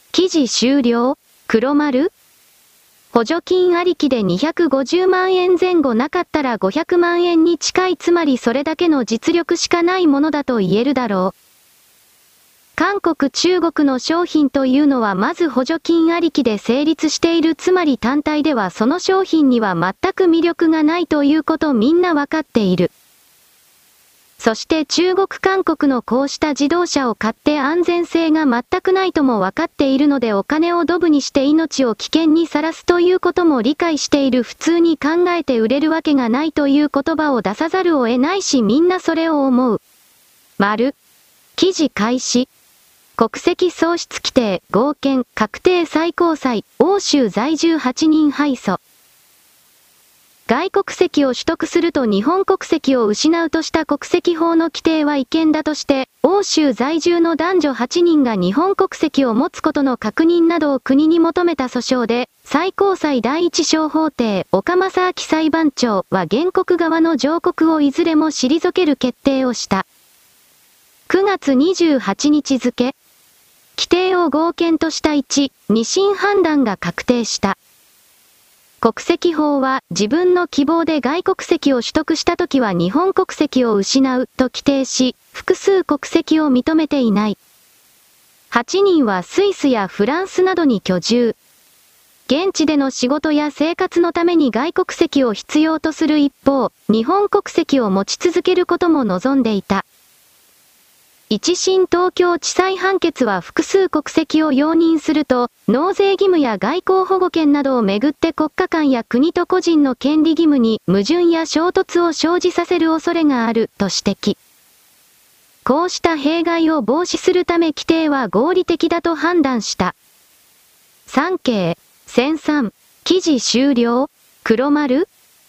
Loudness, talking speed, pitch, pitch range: -16 LUFS, 265 characters per minute, 310 Hz, 260-345 Hz